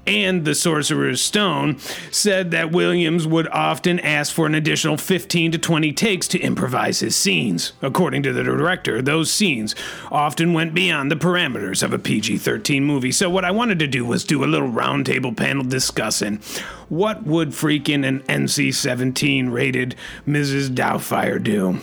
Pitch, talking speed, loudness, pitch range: 155 Hz, 160 wpm, -19 LUFS, 140-180 Hz